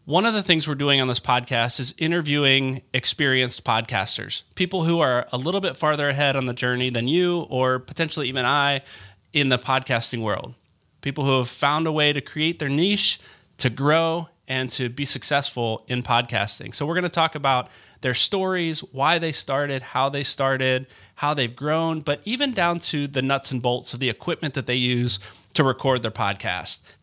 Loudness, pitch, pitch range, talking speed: -22 LUFS, 135 Hz, 125-155 Hz, 195 wpm